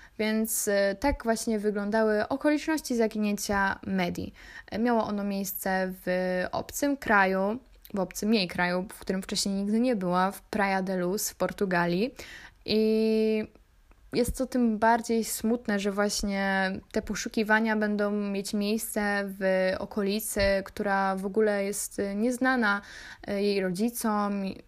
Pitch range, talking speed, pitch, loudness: 195-220 Hz, 125 wpm, 205 Hz, -28 LUFS